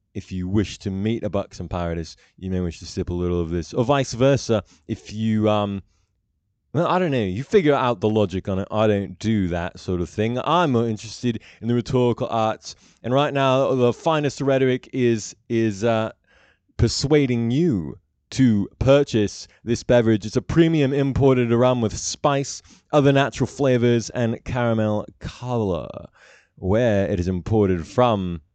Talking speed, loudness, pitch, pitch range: 170 wpm, -21 LUFS, 115 Hz, 100-130 Hz